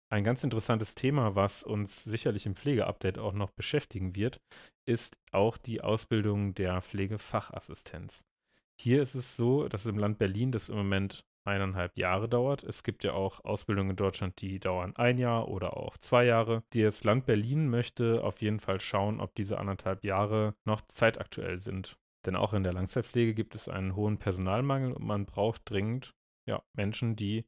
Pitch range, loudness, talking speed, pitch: 100-115 Hz, -32 LUFS, 175 wpm, 105 Hz